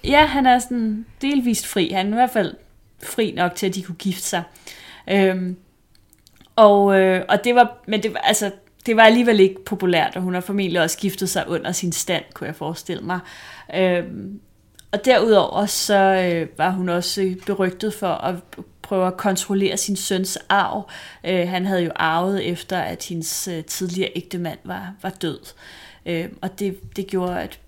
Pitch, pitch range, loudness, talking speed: 190 Hz, 180-205 Hz, -20 LUFS, 185 wpm